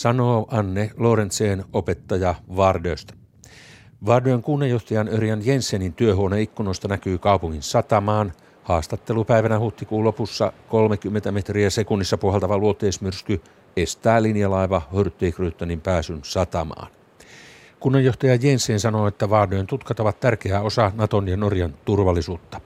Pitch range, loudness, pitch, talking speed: 95-115 Hz, -21 LUFS, 105 Hz, 105 wpm